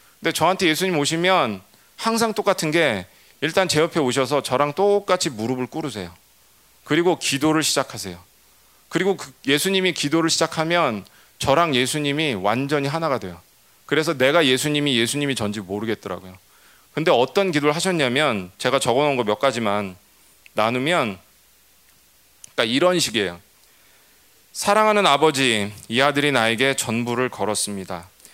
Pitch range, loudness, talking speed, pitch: 110-165 Hz, -20 LUFS, 330 characters per minute, 140 Hz